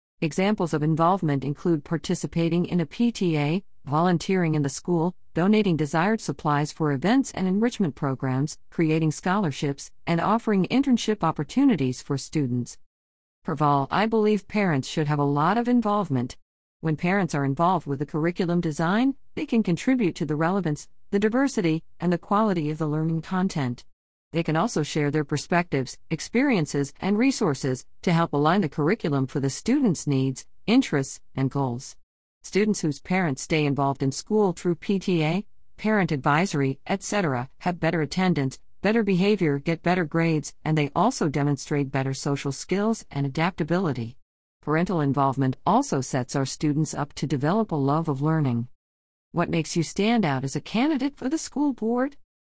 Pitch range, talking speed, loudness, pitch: 140-195 Hz, 155 wpm, -25 LUFS, 160 Hz